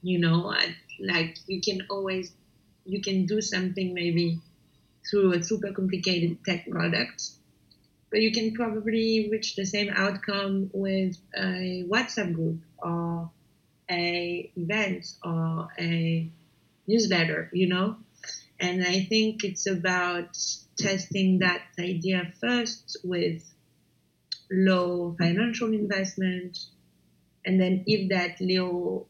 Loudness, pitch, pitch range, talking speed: -27 LUFS, 185 Hz, 170-200 Hz, 115 wpm